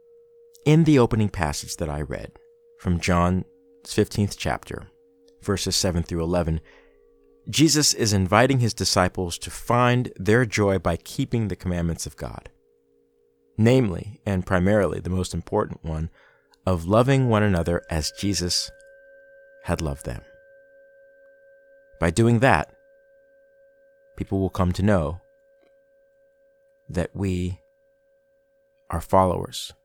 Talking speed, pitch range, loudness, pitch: 115 wpm, 90-115 Hz, -23 LUFS, 95 Hz